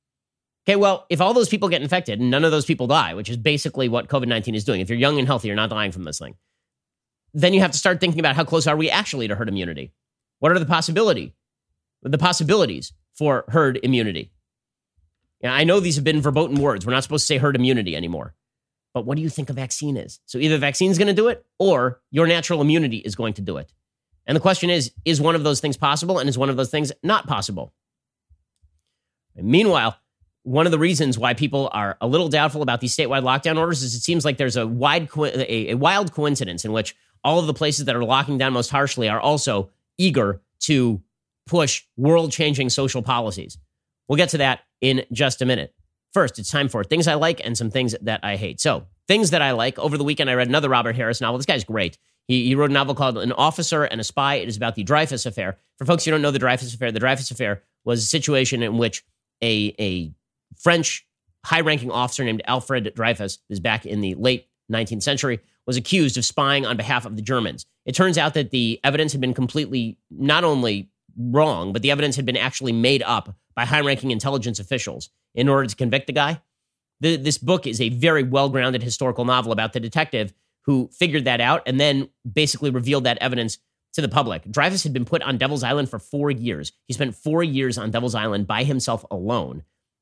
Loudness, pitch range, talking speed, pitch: -21 LUFS, 115-150 Hz, 225 wpm, 130 Hz